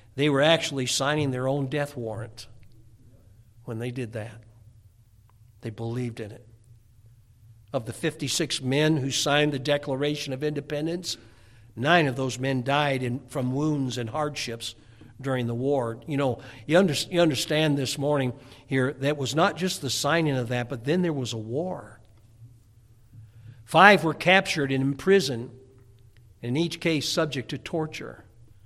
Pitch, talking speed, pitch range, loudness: 130 Hz, 155 wpm, 115-150 Hz, -25 LUFS